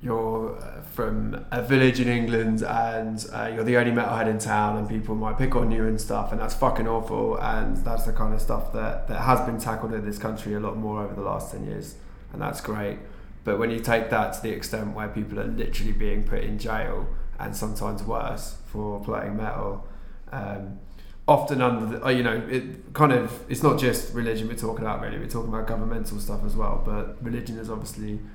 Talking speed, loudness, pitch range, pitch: 215 wpm, -27 LUFS, 105-115 Hz, 110 Hz